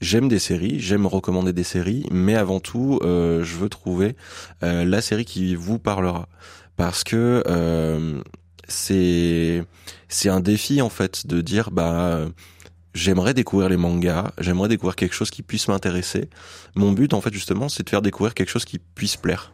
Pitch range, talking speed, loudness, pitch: 85-100 Hz, 175 wpm, -22 LUFS, 95 Hz